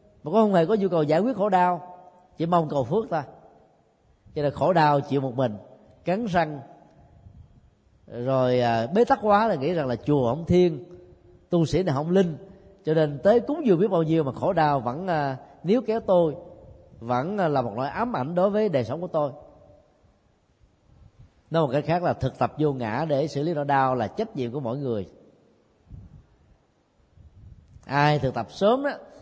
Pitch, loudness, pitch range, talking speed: 155 Hz, -24 LUFS, 130-180 Hz, 190 wpm